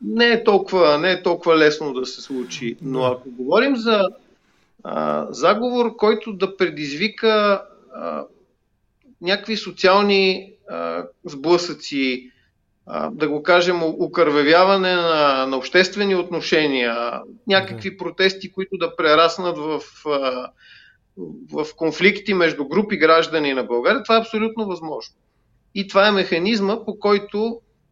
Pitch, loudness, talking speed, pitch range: 180 Hz, -19 LUFS, 125 wpm, 150-205 Hz